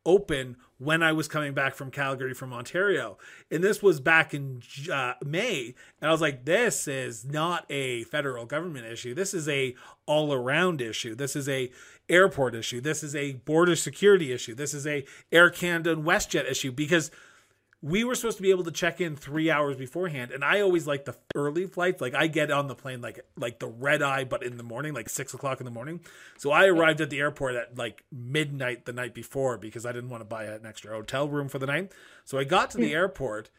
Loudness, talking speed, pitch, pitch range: -27 LUFS, 220 wpm, 145 Hz, 125-160 Hz